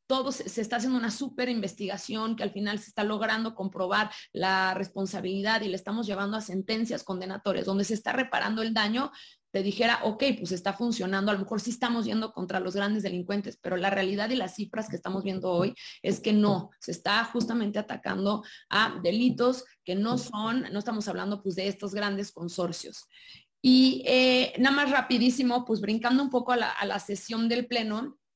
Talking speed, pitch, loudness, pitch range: 195 wpm, 215 Hz, -28 LUFS, 195-240 Hz